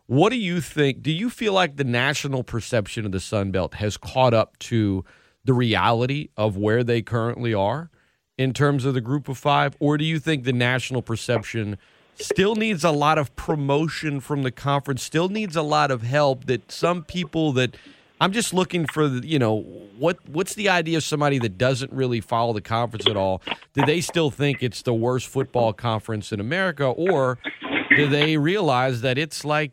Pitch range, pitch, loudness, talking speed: 115-155 Hz, 135 Hz, -22 LUFS, 200 wpm